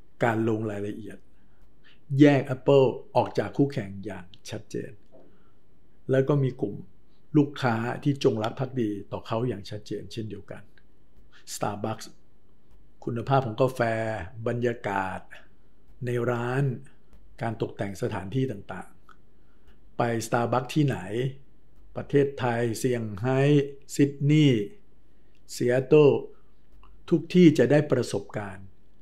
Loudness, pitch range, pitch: -26 LUFS, 105-135 Hz, 120 Hz